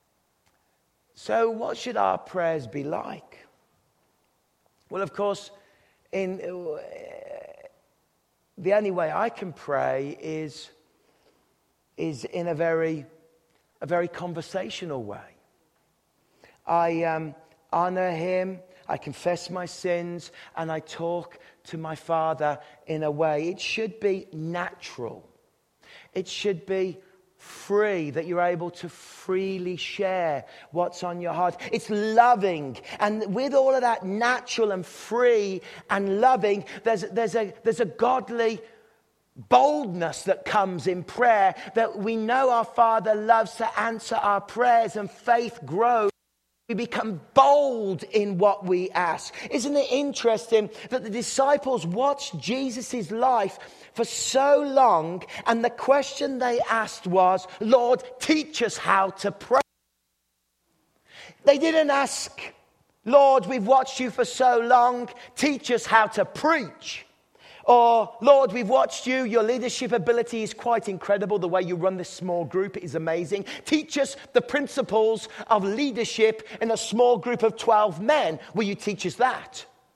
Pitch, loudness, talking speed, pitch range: 210 Hz, -24 LUFS, 135 wpm, 180-240 Hz